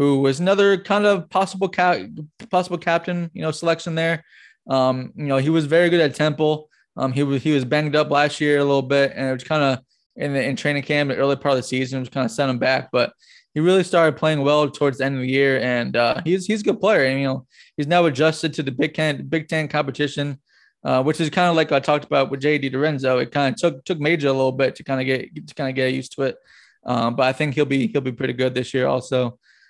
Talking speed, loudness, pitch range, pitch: 270 wpm, -20 LUFS, 135-160 Hz, 145 Hz